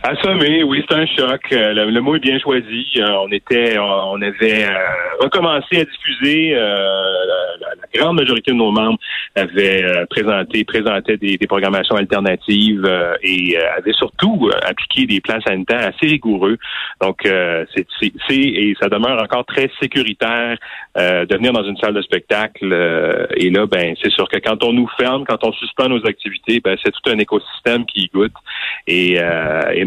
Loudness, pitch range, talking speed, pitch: -15 LUFS, 95-130 Hz, 190 wpm, 110 Hz